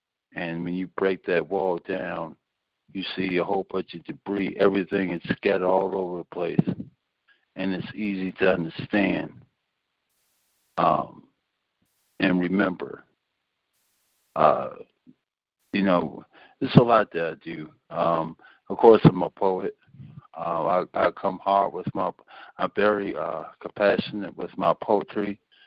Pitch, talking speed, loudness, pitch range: 95 Hz, 135 wpm, -25 LUFS, 90-100 Hz